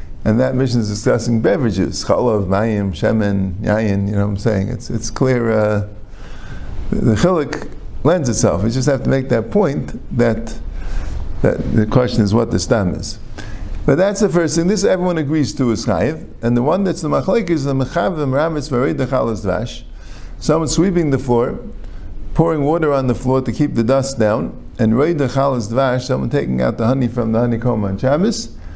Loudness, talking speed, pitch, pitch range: -17 LUFS, 185 wpm, 120 Hz, 105-135 Hz